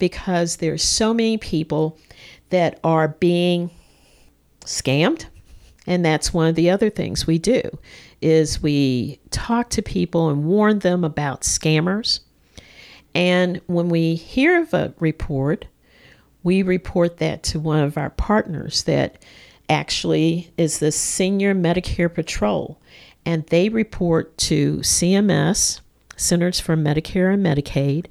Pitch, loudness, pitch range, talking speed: 170 Hz, -20 LUFS, 155-180 Hz, 130 wpm